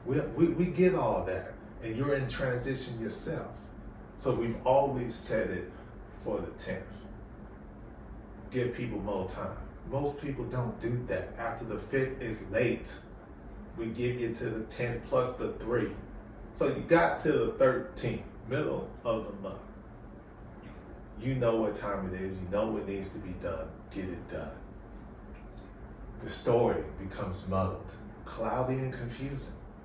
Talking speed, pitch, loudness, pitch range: 150 wpm, 115 Hz, -33 LUFS, 105-130 Hz